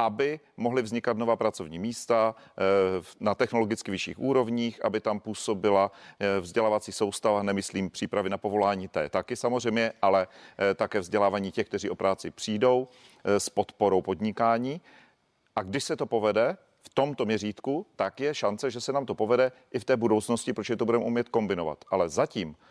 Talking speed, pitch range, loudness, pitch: 160 wpm, 100-120 Hz, -28 LUFS, 110 Hz